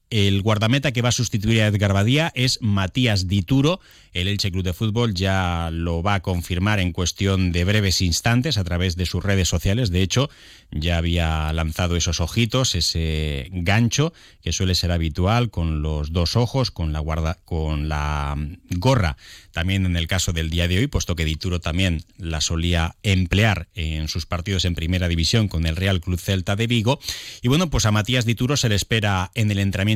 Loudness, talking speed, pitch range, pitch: -21 LUFS, 190 wpm, 85-110 Hz, 95 Hz